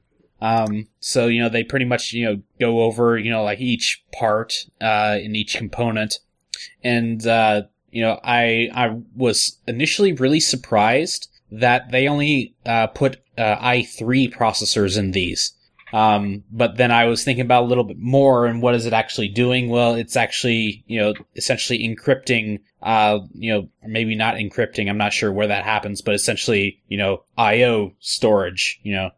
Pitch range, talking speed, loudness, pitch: 105-120 Hz, 175 wpm, -19 LUFS, 115 Hz